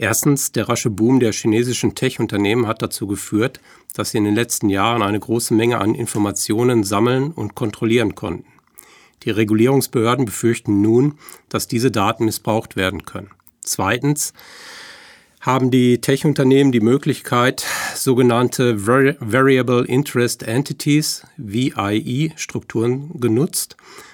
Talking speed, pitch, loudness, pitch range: 120 wpm, 120 Hz, -18 LUFS, 110-130 Hz